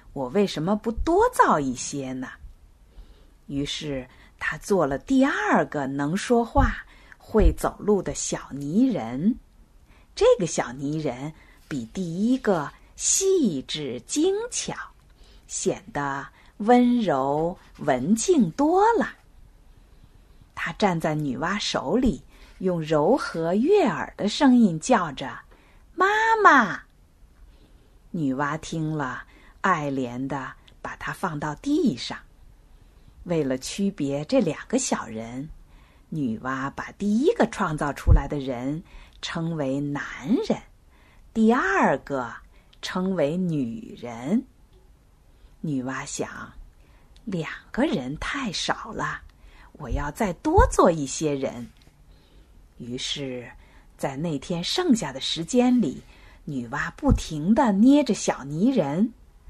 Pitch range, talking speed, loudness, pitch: 140-235 Hz, 150 characters per minute, -24 LUFS, 170 Hz